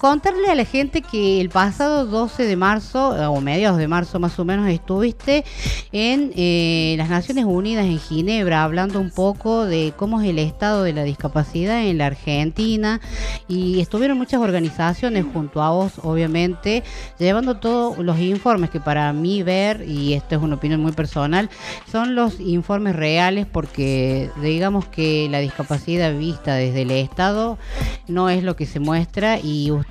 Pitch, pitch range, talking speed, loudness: 180 Hz, 155-215 Hz, 165 wpm, -20 LUFS